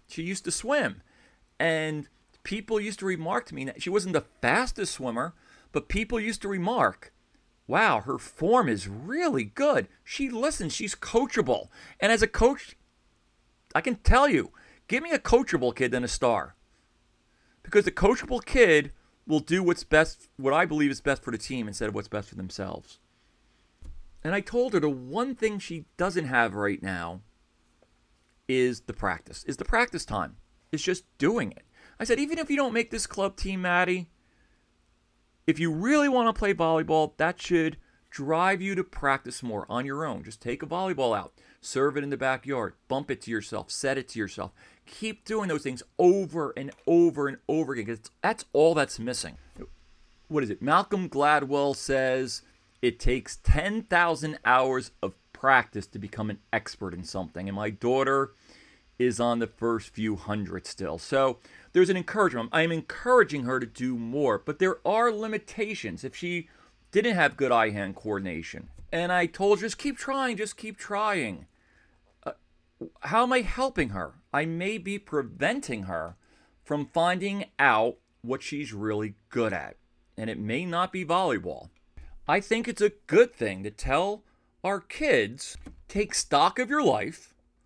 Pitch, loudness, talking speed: 155 Hz, -27 LUFS, 175 wpm